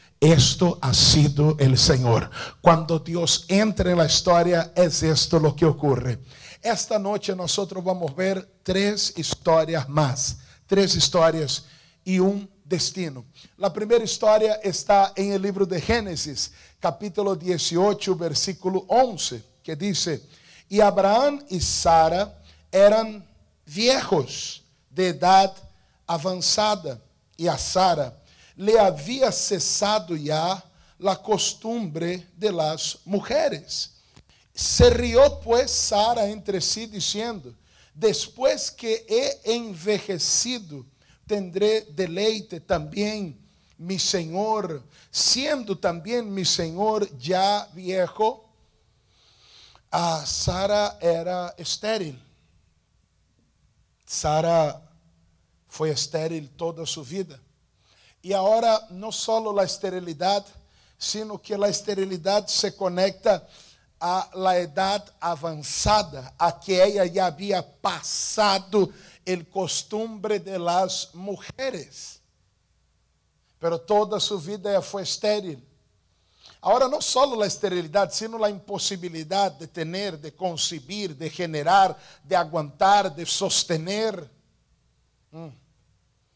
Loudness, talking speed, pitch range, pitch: -23 LUFS, 105 wpm, 155-205 Hz, 185 Hz